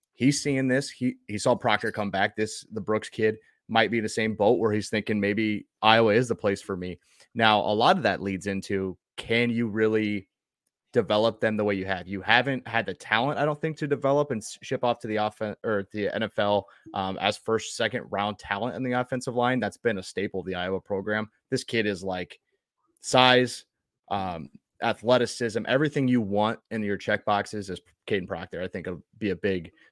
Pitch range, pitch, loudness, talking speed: 100-120 Hz, 110 Hz, -26 LUFS, 215 wpm